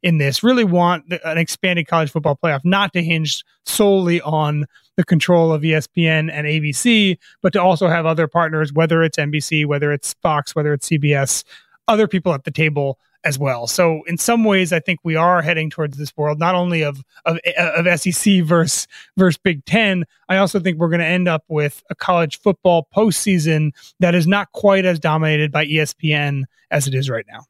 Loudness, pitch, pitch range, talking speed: -17 LUFS, 165 Hz, 150-180 Hz, 195 wpm